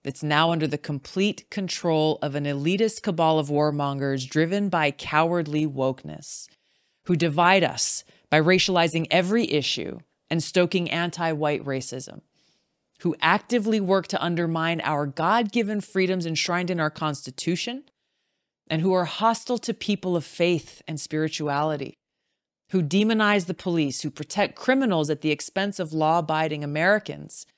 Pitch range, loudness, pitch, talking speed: 150-190 Hz, -24 LUFS, 165 Hz, 140 wpm